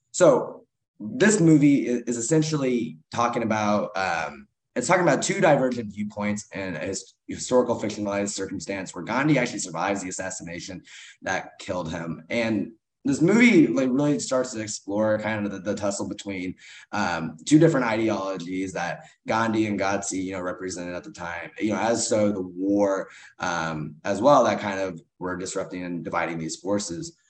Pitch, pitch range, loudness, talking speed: 105 Hz, 95-120 Hz, -24 LUFS, 165 wpm